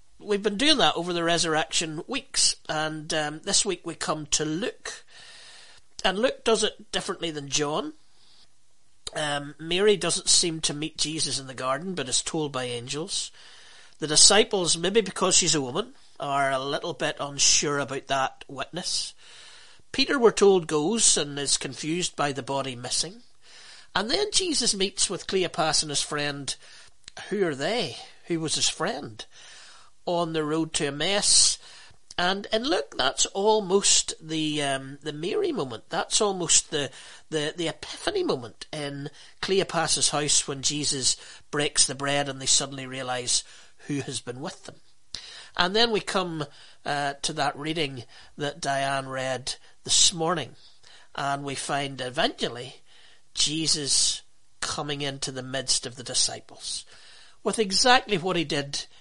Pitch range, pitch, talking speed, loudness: 140-180 Hz, 155 Hz, 155 wpm, -25 LUFS